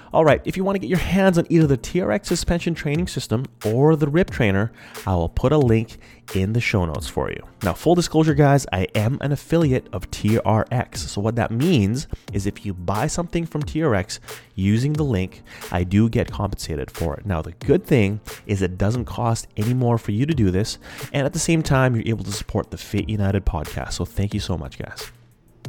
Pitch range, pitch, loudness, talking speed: 100-145 Hz, 115 Hz, -21 LUFS, 220 wpm